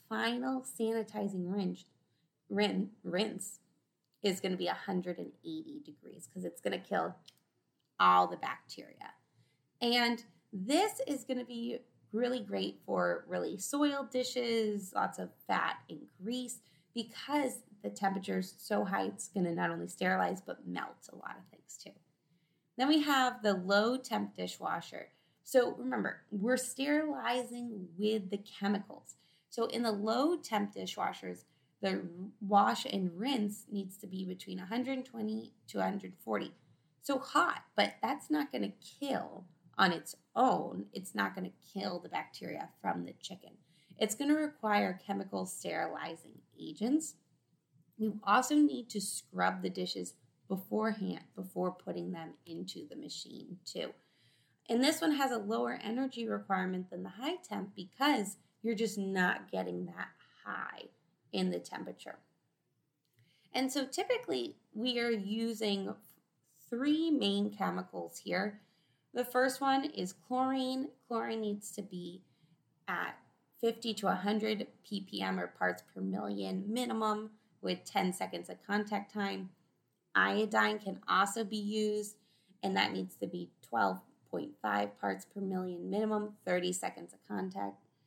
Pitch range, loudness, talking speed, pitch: 175-240 Hz, -35 LUFS, 135 wpm, 205 Hz